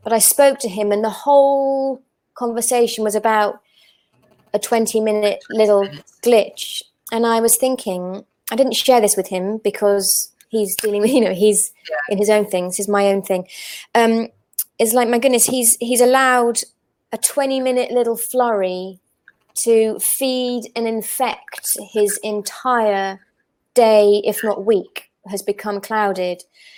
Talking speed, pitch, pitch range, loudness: 150 wpm, 220 Hz, 205-240 Hz, -17 LUFS